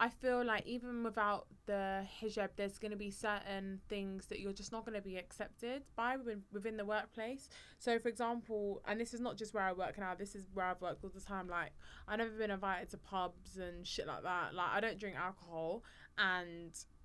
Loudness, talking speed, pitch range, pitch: -42 LUFS, 220 wpm, 190-225 Hz, 205 Hz